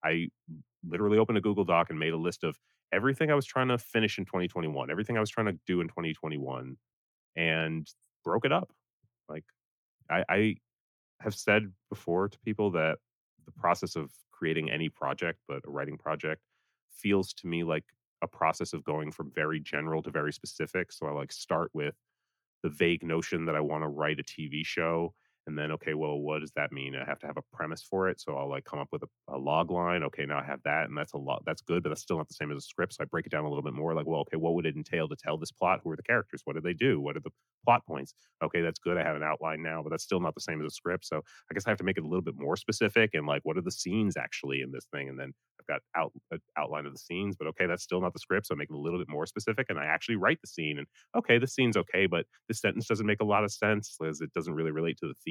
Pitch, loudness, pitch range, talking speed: 80 Hz, -32 LUFS, 75-100 Hz, 275 wpm